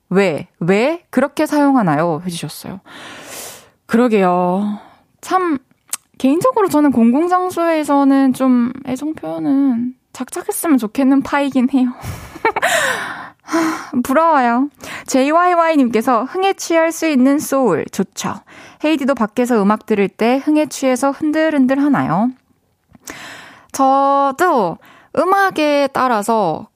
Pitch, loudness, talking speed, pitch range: 270 Hz, -15 LUFS, 240 characters per minute, 240-310 Hz